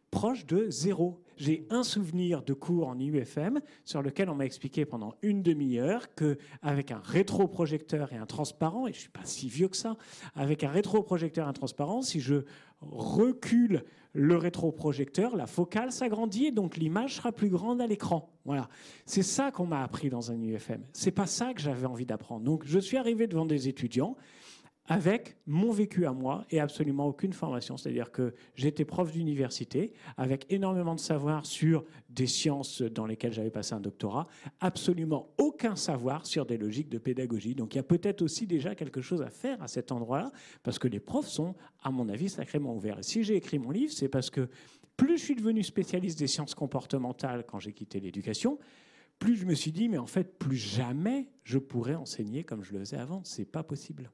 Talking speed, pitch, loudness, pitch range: 200 wpm, 155 Hz, -32 LUFS, 135-195 Hz